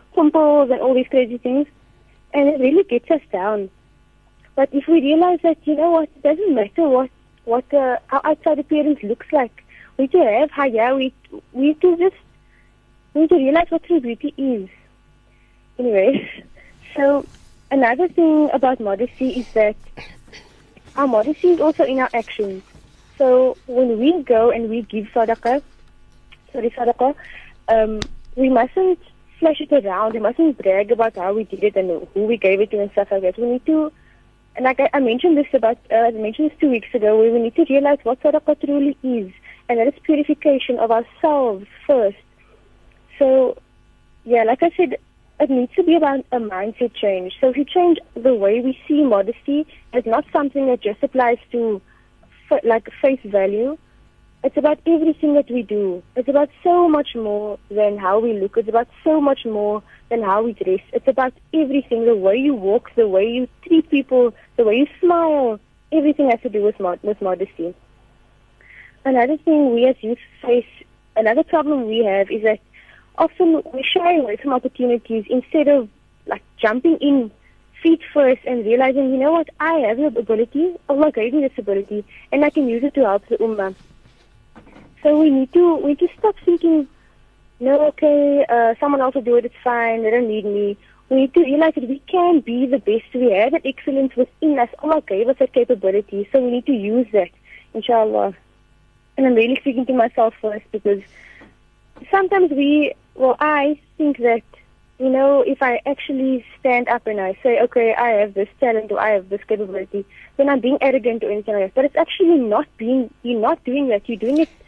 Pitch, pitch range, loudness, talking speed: 255 Hz, 225-295 Hz, -18 LUFS, 190 wpm